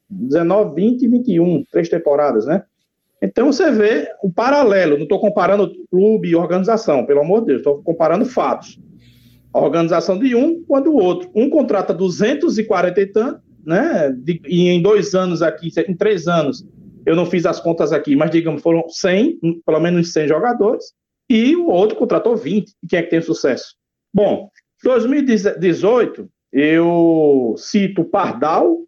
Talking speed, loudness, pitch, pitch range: 160 wpm, -16 LUFS, 185 Hz, 165-220 Hz